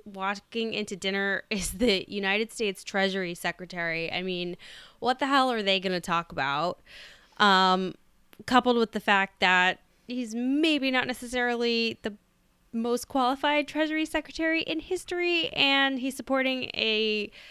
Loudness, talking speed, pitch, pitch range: -26 LUFS, 140 wpm, 225 Hz, 190-260 Hz